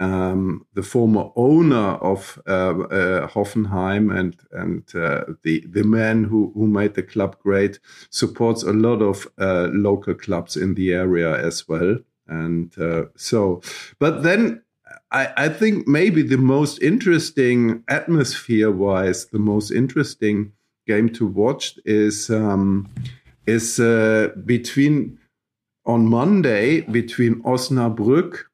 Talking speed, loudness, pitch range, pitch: 130 wpm, -19 LUFS, 95-120 Hz, 110 Hz